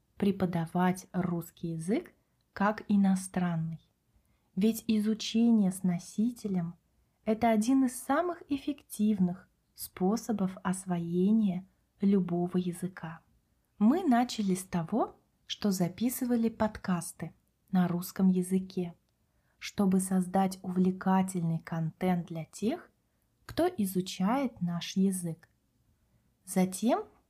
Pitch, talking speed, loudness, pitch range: 190 Hz, 85 wpm, -31 LUFS, 180-220 Hz